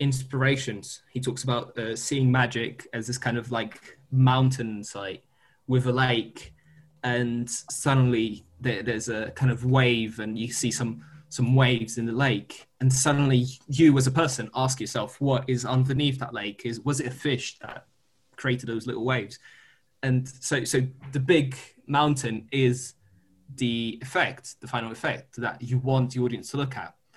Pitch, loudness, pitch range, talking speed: 125 Hz, -26 LUFS, 115-135 Hz, 170 wpm